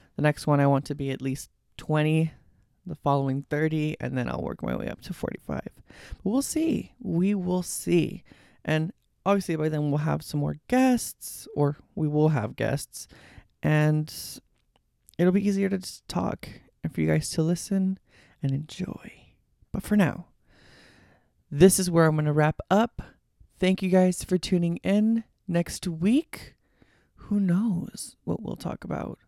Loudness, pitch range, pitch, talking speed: -26 LUFS, 150-195 Hz, 165 Hz, 170 wpm